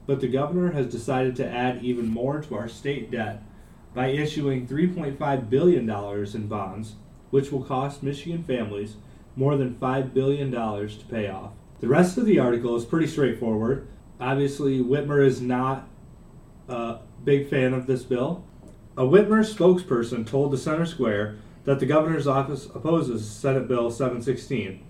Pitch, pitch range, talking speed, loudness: 130 Hz, 115-140 Hz, 155 wpm, -25 LUFS